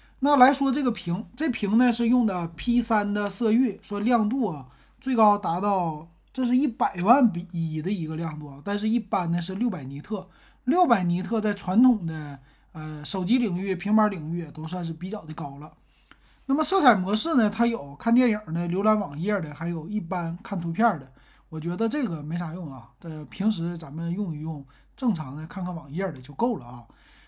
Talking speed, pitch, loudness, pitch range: 280 characters per minute, 195 Hz, -25 LUFS, 165-230 Hz